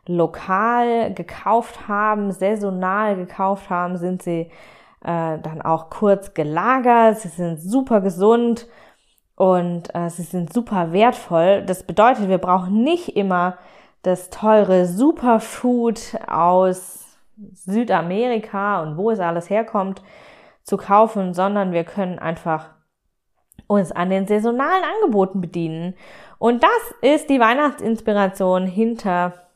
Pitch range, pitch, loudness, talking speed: 180-225 Hz, 195 Hz, -19 LUFS, 115 wpm